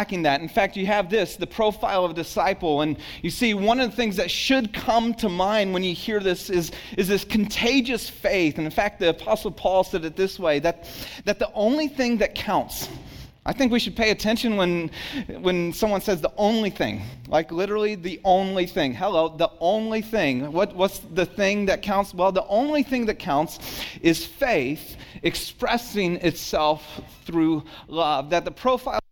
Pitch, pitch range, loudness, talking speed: 195 Hz, 170-220 Hz, -23 LUFS, 190 wpm